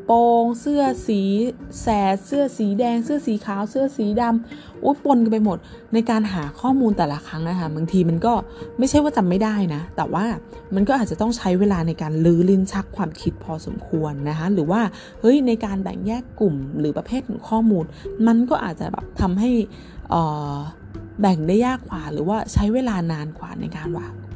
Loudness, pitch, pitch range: -21 LUFS, 205 Hz, 170-235 Hz